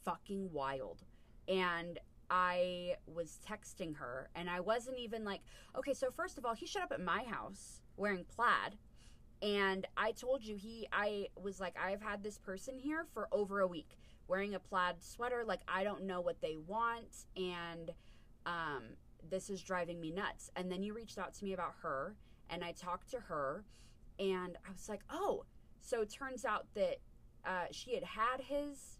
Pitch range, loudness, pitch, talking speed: 180-230 Hz, -41 LUFS, 195 Hz, 185 wpm